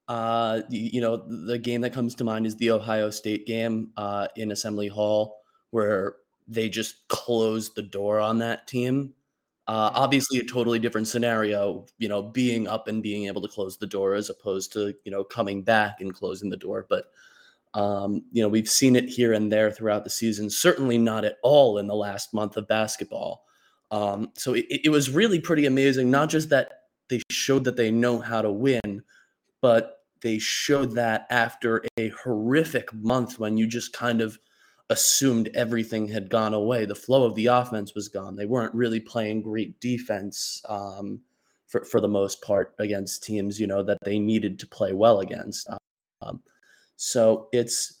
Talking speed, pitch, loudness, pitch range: 185 wpm, 110 Hz, -25 LUFS, 105-120 Hz